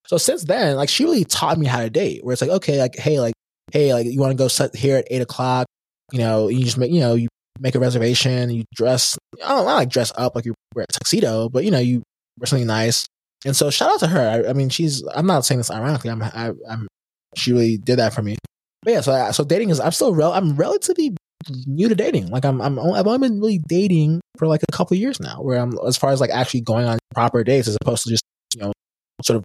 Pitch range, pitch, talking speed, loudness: 120-155 Hz, 130 Hz, 270 wpm, -19 LUFS